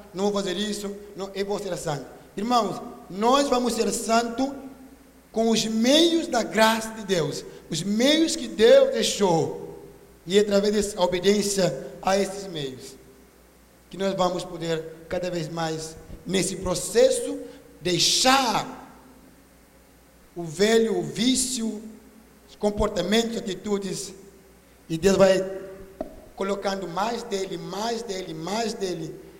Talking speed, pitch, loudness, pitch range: 125 wpm, 200 Hz, -24 LUFS, 185-230 Hz